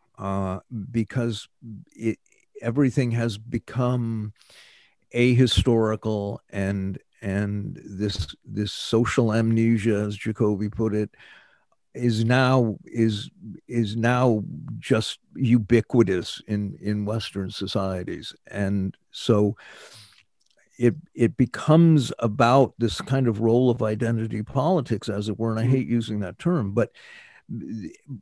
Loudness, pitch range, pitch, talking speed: -24 LUFS, 105-120 Hz, 115 Hz, 110 wpm